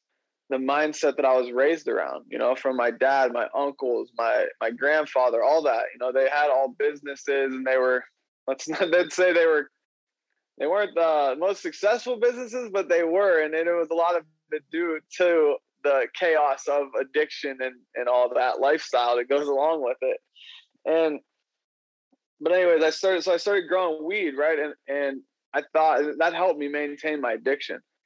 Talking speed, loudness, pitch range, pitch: 190 wpm, -24 LUFS, 135-185 Hz, 155 Hz